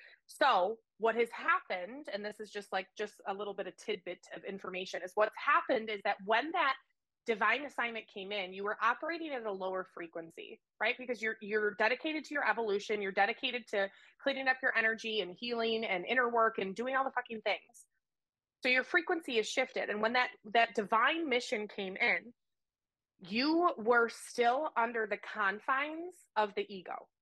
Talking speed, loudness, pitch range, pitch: 185 wpm, -34 LUFS, 205-255 Hz, 225 Hz